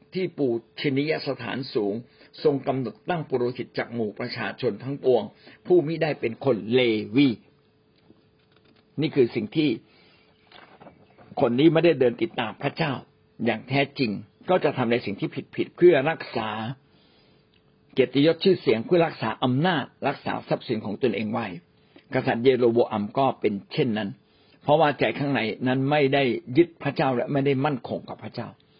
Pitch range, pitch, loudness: 120-150 Hz, 135 Hz, -24 LUFS